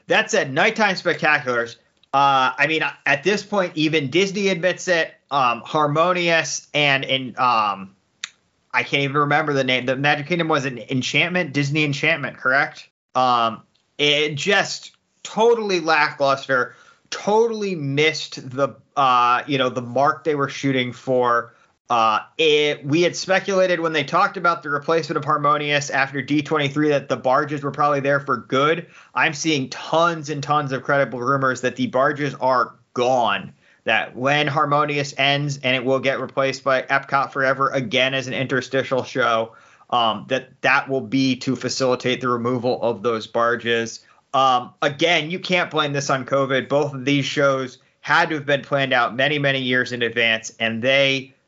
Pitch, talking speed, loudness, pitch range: 140 Hz, 165 wpm, -20 LUFS, 130-155 Hz